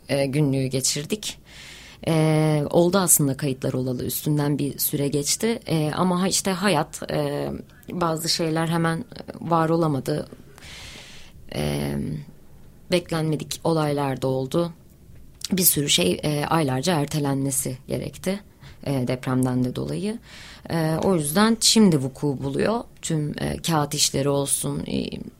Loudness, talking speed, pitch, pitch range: -23 LUFS, 95 wpm, 150 Hz, 135-170 Hz